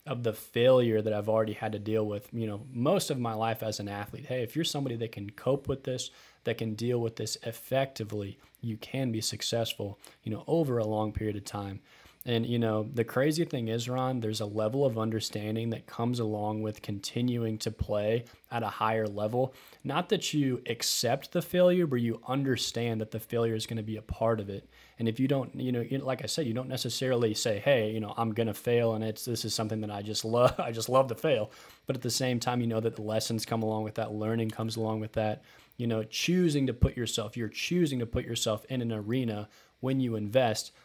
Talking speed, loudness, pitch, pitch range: 235 wpm, -31 LUFS, 115 Hz, 110-130 Hz